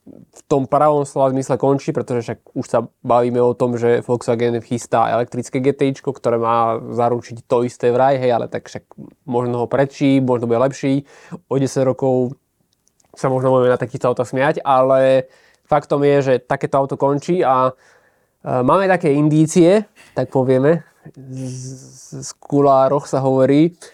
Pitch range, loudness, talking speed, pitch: 125-140 Hz, -17 LUFS, 155 wpm, 130 Hz